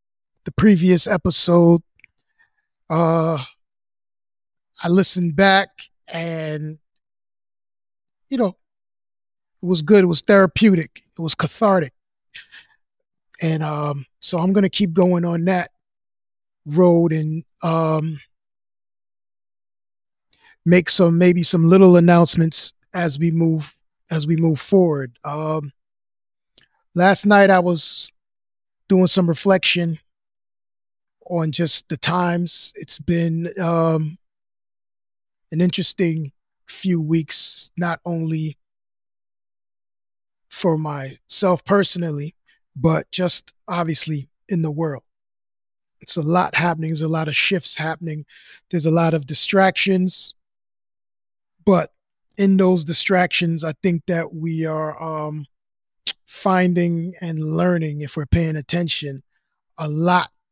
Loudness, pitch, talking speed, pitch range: -19 LUFS, 165 Hz, 110 wpm, 150-180 Hz